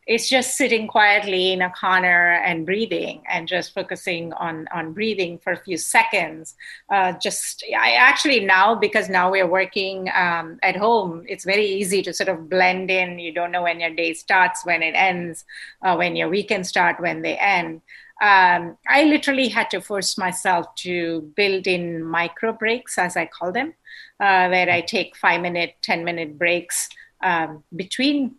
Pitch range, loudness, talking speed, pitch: 175-205 Hz, -19 LUFS, 180 wpm, 185 Hz